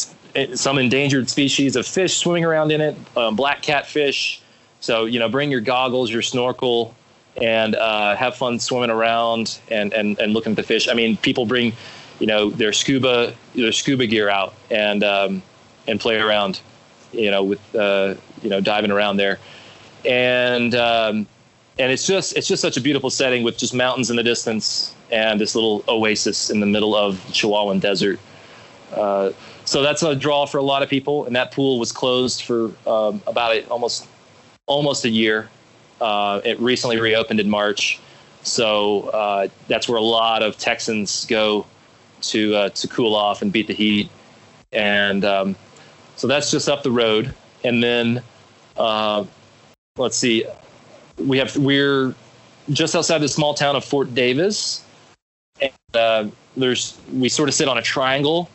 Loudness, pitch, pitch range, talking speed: -19 LUFS, 120 Hz, 105-135 Hz, 170 wpm